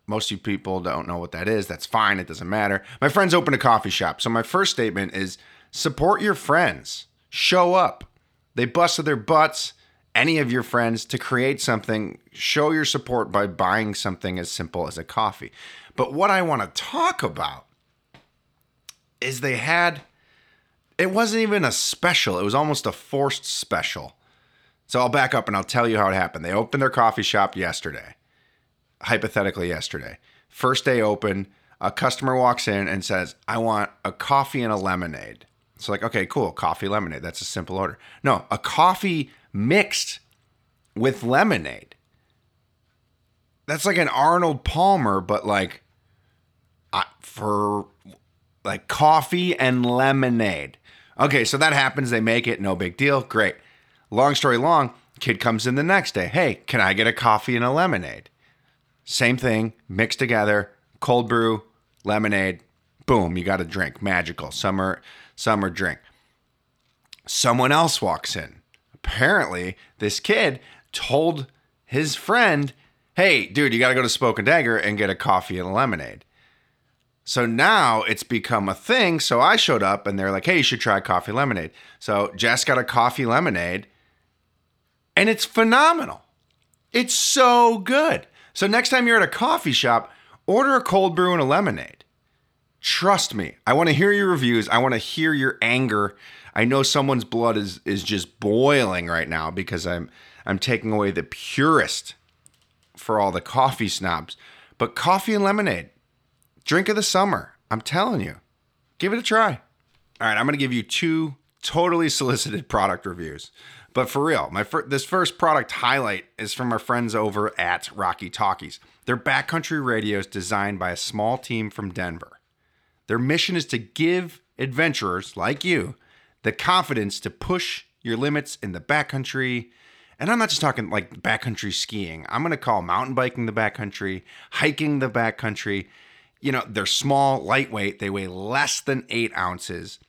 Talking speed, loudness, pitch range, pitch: 165 wpm, -22 LUFS, 100-145 Hz, 120 Hz